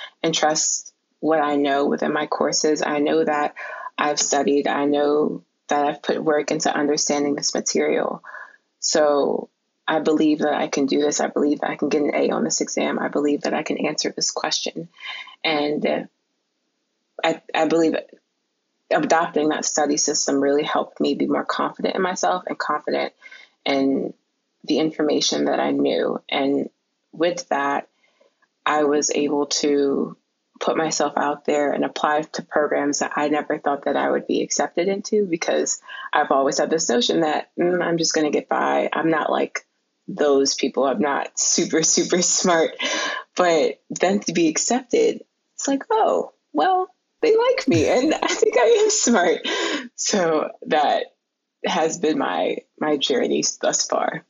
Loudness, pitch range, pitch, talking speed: -21 LUFS, 145-170 Hz, 150 Hz, 165 wpm